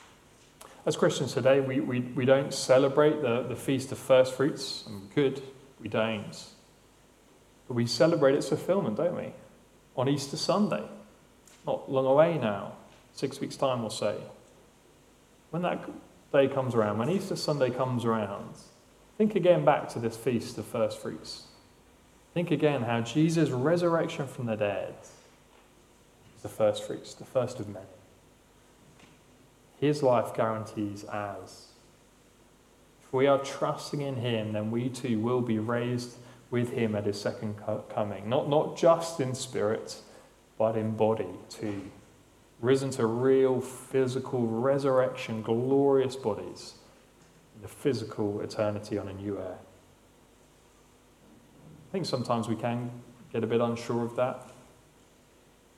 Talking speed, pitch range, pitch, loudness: 140 wpm, 110-135 Hz, 125 Hz, -29 LUFS